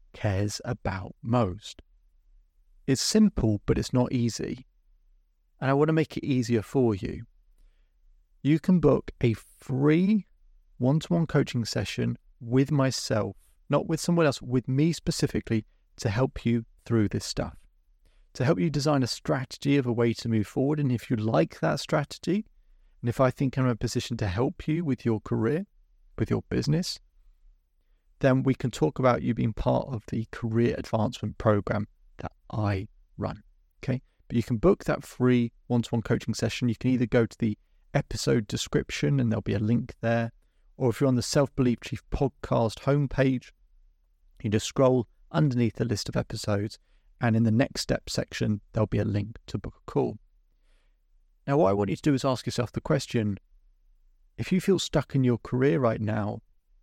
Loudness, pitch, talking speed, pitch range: -27 LUFS, 115 Hz, 185 wpm, 100-135 Hz